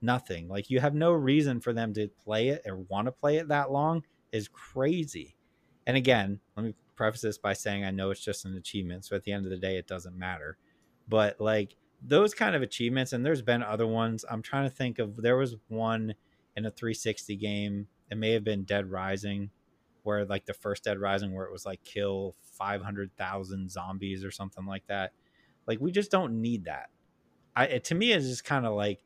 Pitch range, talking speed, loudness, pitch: 100-125 Hz, 215 wpm, -31 LUFS, 105 Hz